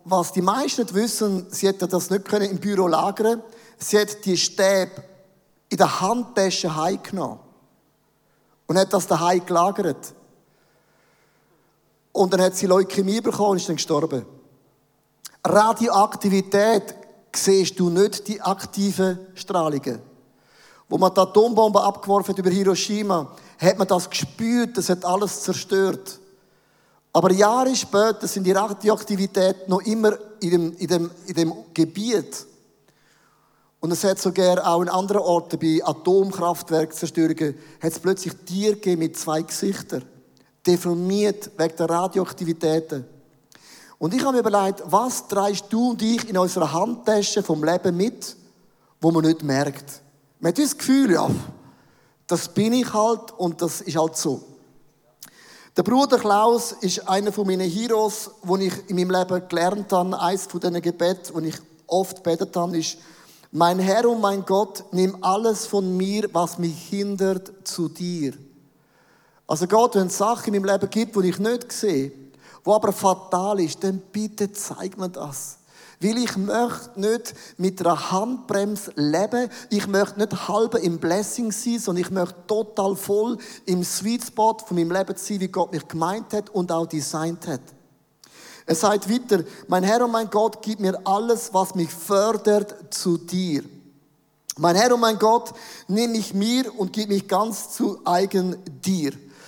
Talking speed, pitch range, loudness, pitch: 155 wpm, 175-210 Hz, -22 LUFS, 190 Hz